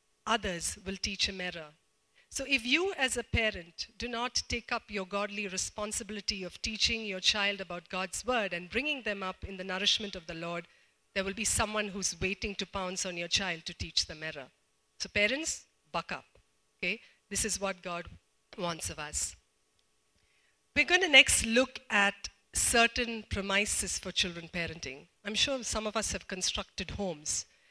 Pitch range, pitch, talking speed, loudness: 180-225 Hz, 200 Hz, 175 wpm, -31 LUFS